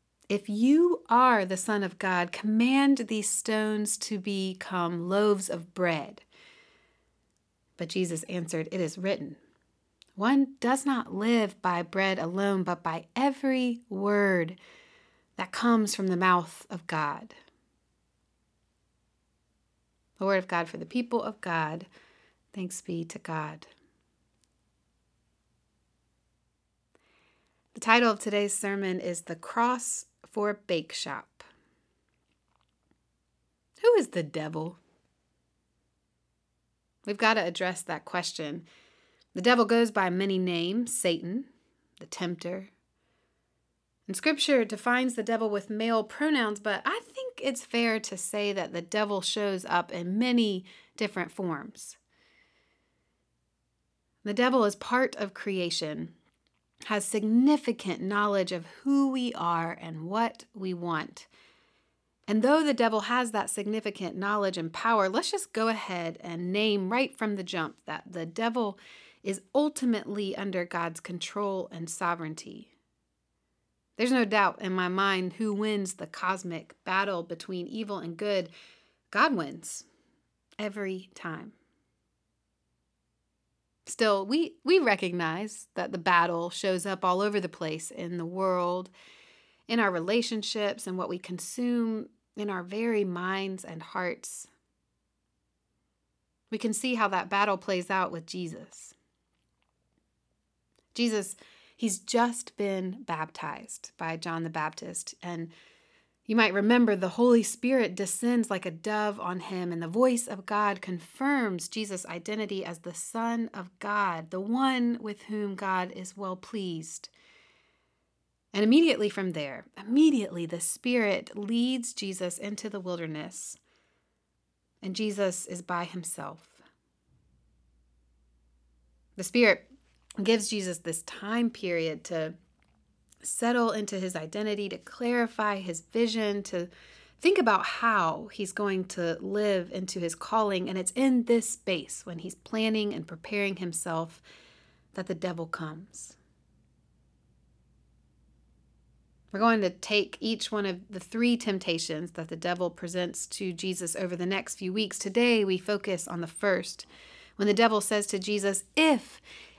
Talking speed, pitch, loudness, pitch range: 130 wpm, 200 Hz, -29 LUFS, 175-225 Hz